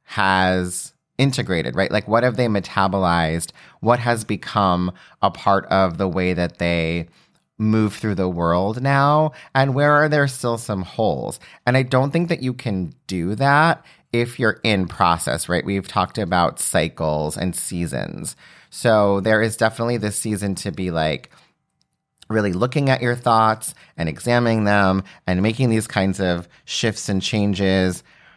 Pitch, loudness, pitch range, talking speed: 105 Hz, -20 LUFS, 95-120 Hz, 160 wpm